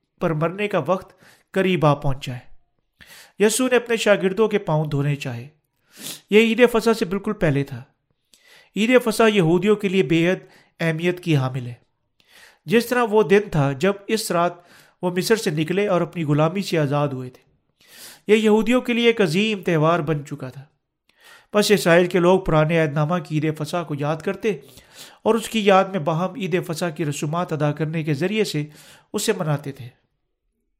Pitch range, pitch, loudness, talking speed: 150-205 Hz, 175 Hz, -20 LUFS, 180 wpm